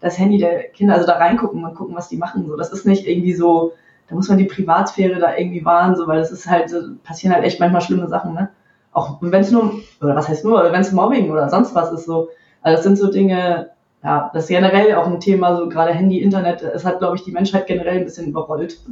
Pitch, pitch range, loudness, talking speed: 175 Hz, 170-195 Hz, -17 LUFS, 255 wpm